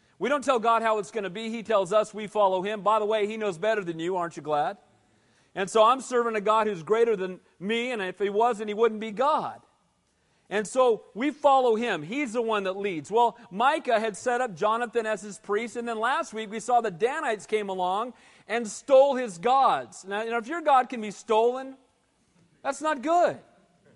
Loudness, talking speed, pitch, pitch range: -26 LUFS, 225 wpm, 220 Hz, 205-245 Hz